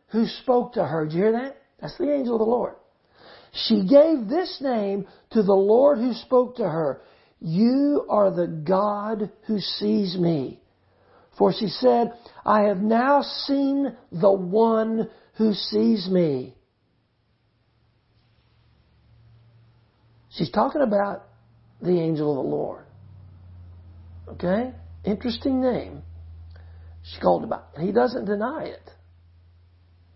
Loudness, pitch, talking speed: -23 LUFS, 195 Hz, 125 wpm